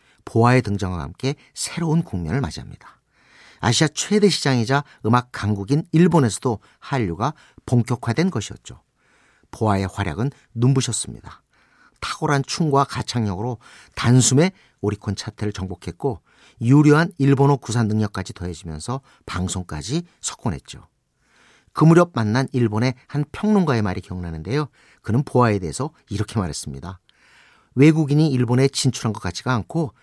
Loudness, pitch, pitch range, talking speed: -21 LUFS, 120 Hz, 105-140 Hz, 325 characters per minute